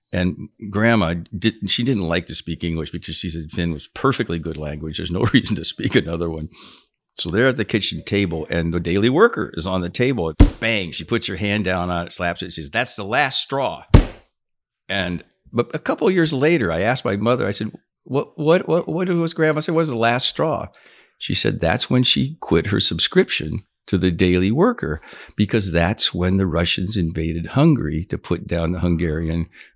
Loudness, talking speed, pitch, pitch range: -20 LUFS, 210 wpm, 90 Hz, 85-115 Hz